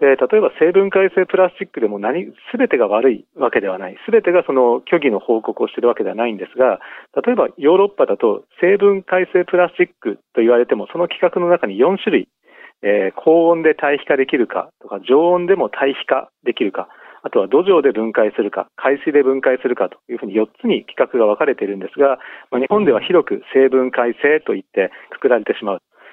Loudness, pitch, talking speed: -16 LUFS, 180 Hz, 400 characters per minute